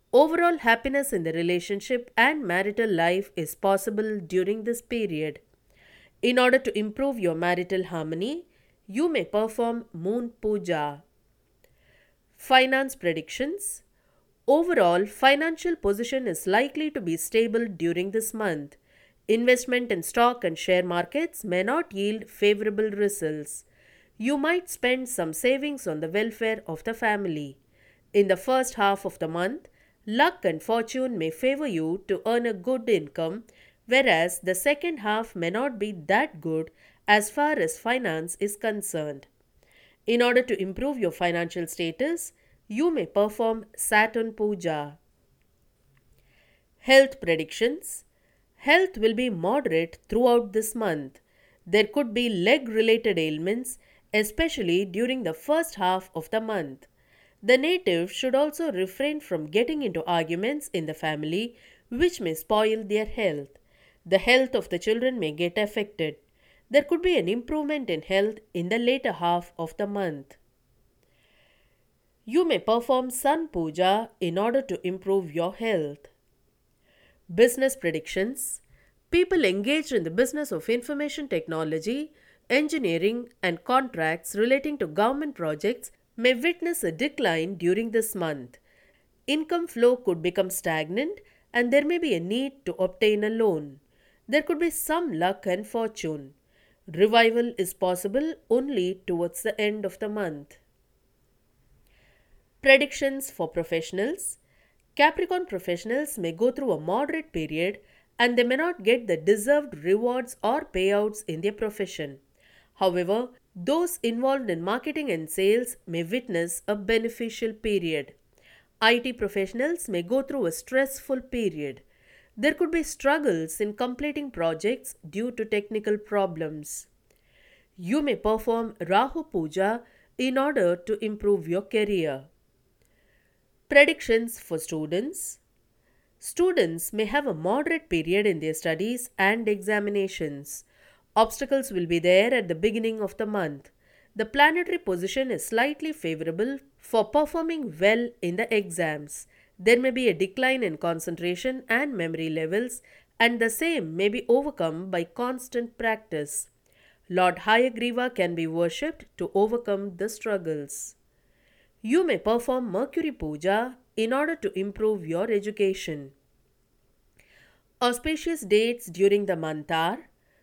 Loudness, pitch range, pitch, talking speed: -26 LUFS, 175-255 Hz, 215 Hz, 135 wpm